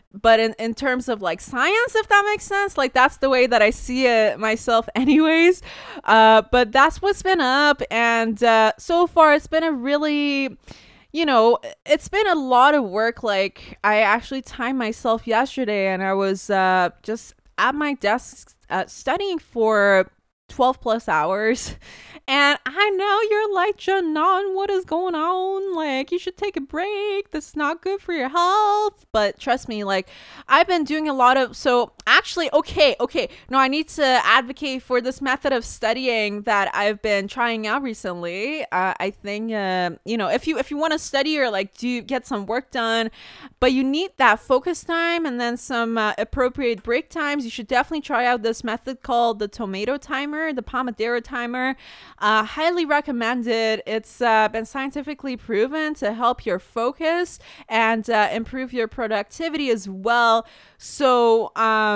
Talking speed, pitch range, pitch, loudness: 180 wpm, 225-300 Hz, 250 Hz, -20 LUFS